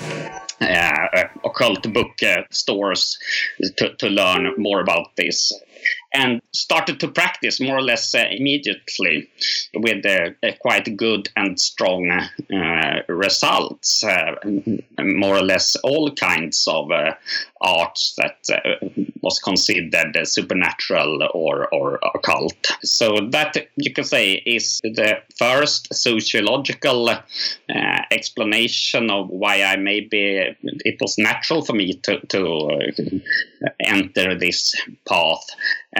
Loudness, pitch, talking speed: -19 LUFS, 115 Hz, 120 wpm